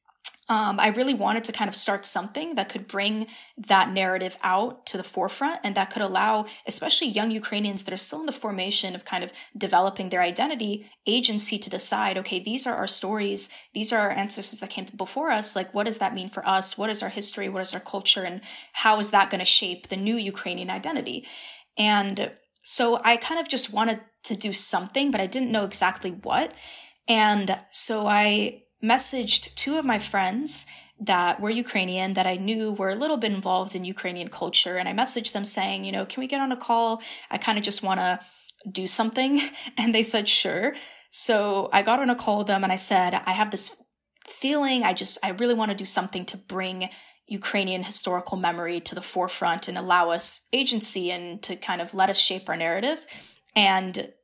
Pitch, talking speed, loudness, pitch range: 205 Hz, 205 wpm, -24 LUFS, 190-225 Hz